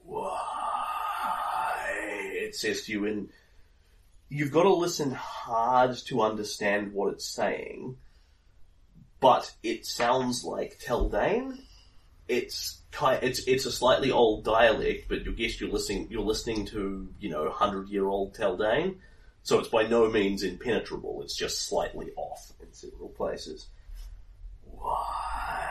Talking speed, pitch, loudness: 135 wpm, 115 Hz, -28 LUFS